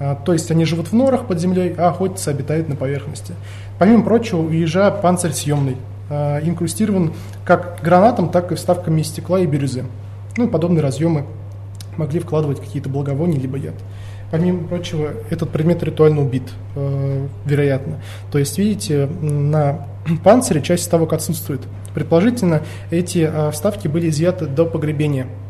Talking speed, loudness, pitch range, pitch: 140 wpm, -18 LUFS, 135-170 Hz, 155 Hz